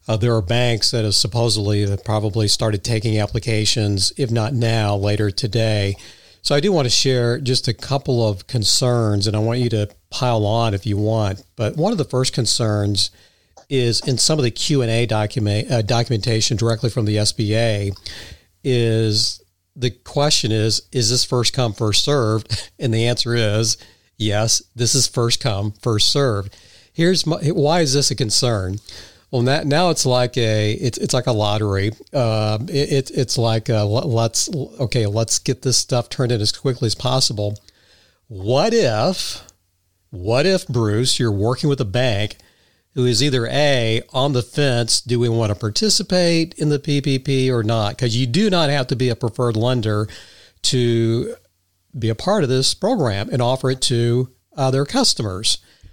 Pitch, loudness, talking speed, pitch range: 115 Hz, -18 LUFS, 170 wpm, 105-130 Hz